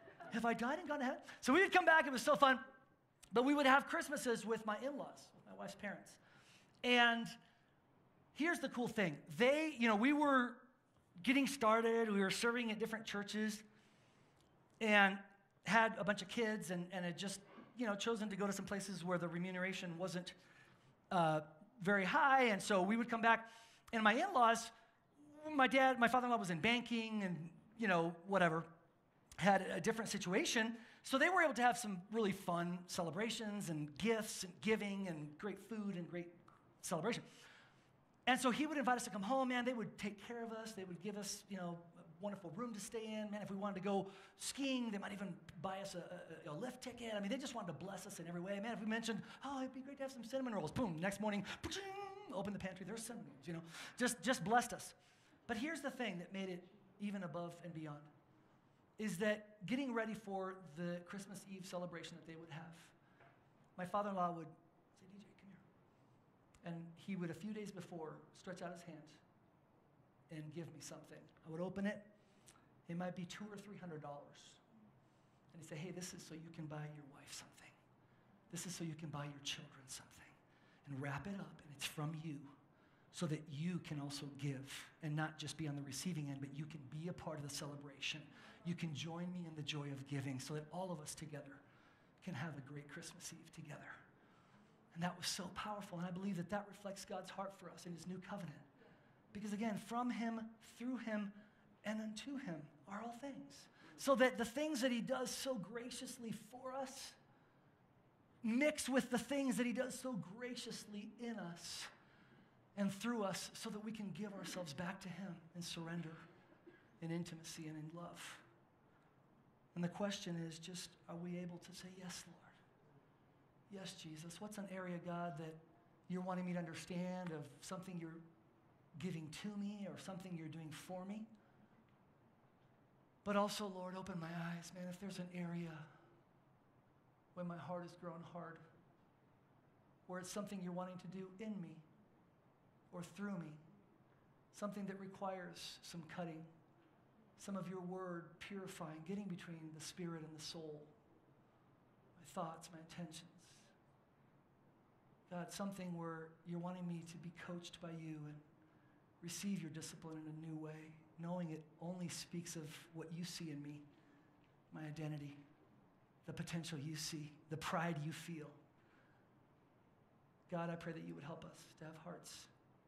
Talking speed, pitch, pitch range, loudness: 190 wpm, 180 Hz, 165-215 Hz, -42 LUFS